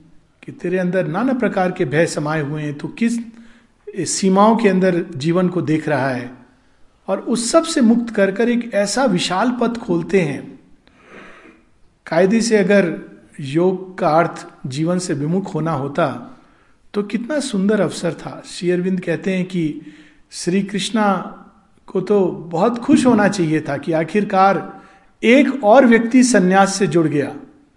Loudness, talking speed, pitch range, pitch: -17 LUFS, 155 wpm, 165-210 Hz, 185 Hz